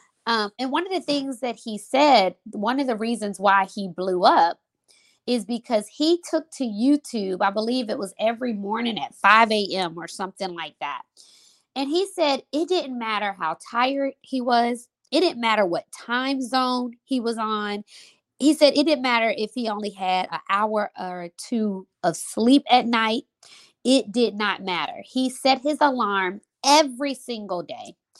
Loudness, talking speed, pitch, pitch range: -23 LUFS, 175 wpm, 235 Hz, 205-270 Hz